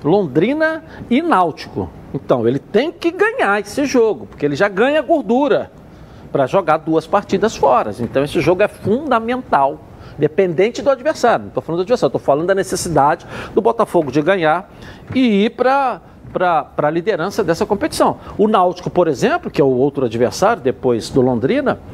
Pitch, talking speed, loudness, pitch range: 200 Hz, 165 wpm, -16 LUFS, 155-250 Hz